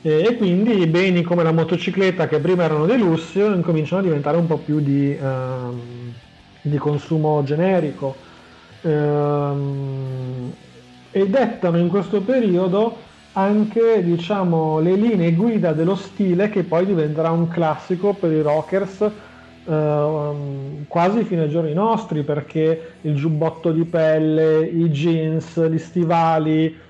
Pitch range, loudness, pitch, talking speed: 150-185 Hz, -19 LUFS, 165 Hz, 130 wpm